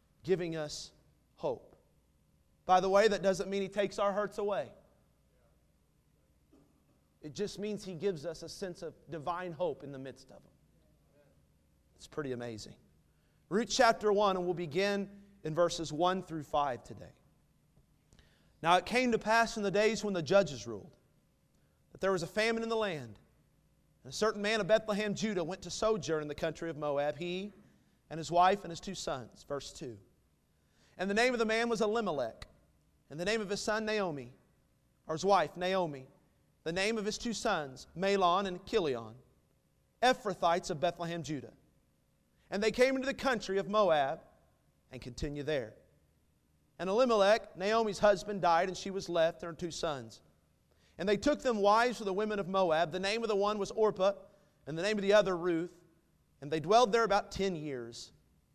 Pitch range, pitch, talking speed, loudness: 155-210 Hz, 185 Hz, 180 wpm, -32 LUFS